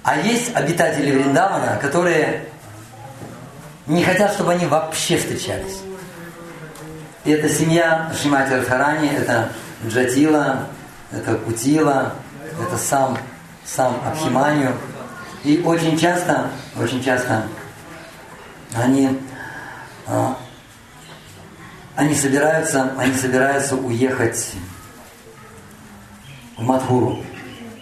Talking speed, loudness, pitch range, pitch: 80 wpm, -19 LUFS, 125-155 Hz, 135 Hz